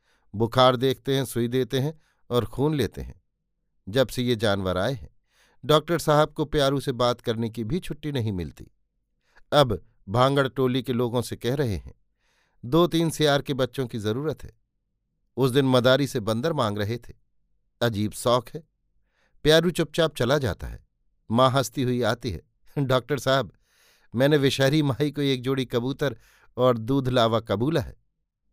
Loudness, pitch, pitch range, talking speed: -24 LUFS, 130 Hz, 115-145 Hz, 170 wpm